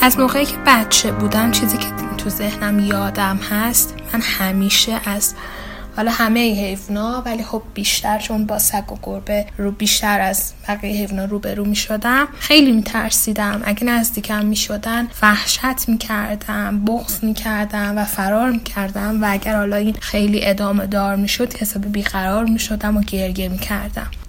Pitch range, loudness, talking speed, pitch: 200-225 Hz, -17 LUFS, 170 wpm, 210 Hz